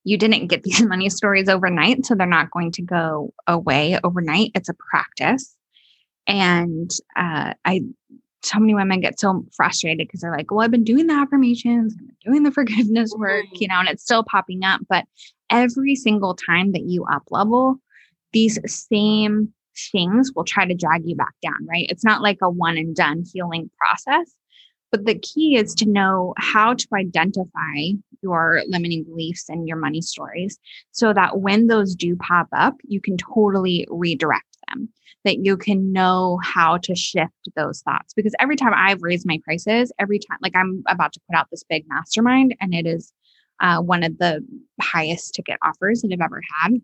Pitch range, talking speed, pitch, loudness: 175-225 Hz, 185 wpm, 195 Hz, -19 LUFS